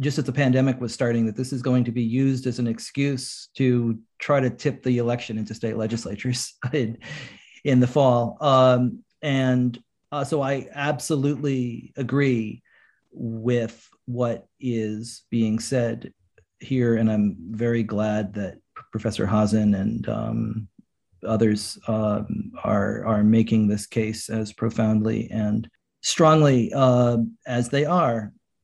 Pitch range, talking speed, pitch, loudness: 110-130 Hz, 140 wpm, 120 Hz, -23 LUFS